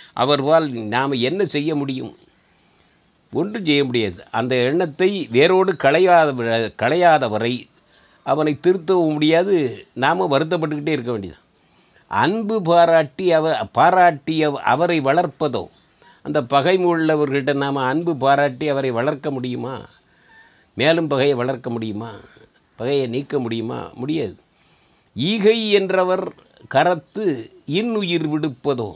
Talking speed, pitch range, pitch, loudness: 100 wpm, 130-170 Hz, 150 Hz, -19 LUFS